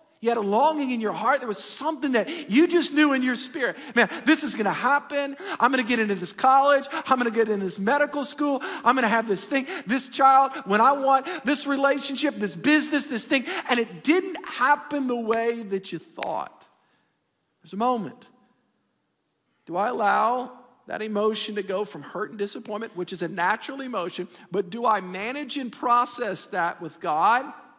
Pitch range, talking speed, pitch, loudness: 215-285 Hz, 200 wpm, 250 Hz, -24 LUFS